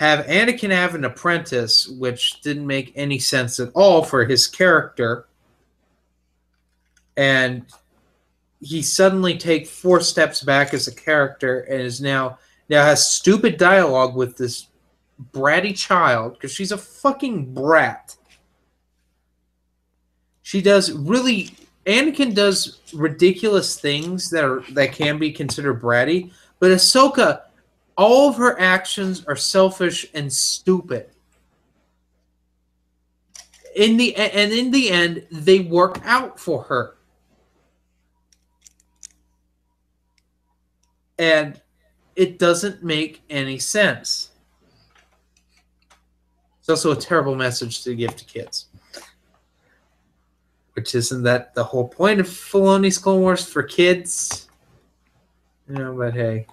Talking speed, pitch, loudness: 115 wpm, 135 Hz, -18 LUFS